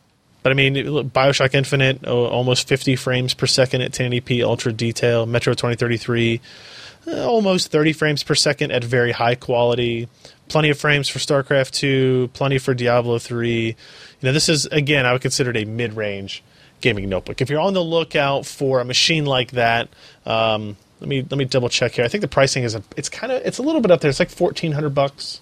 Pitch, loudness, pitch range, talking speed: 130 Hz, -19 LUFS, 120-145 Hz, 200 wpm